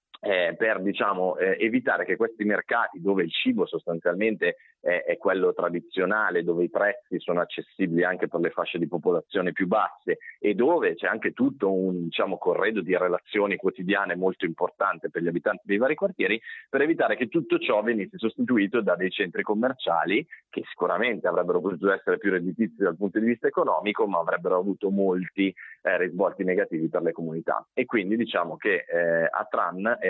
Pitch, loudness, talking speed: 110 Hz, -26 LUFS, 175 wpm